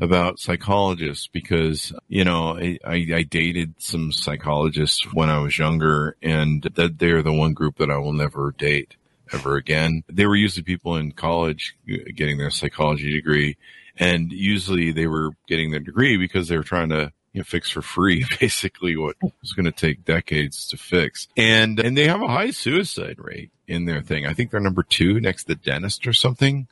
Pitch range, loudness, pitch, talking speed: 75-90 Hz, -21 LUFS, 80 Hz, 190 wpm